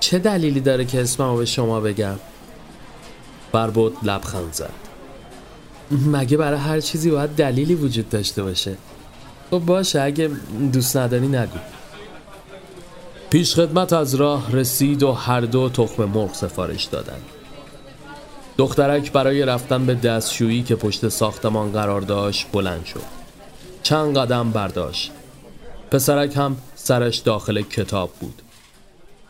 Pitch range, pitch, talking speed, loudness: 110-145 Hz, 130 Hz, 120 wpm, -20 LUFS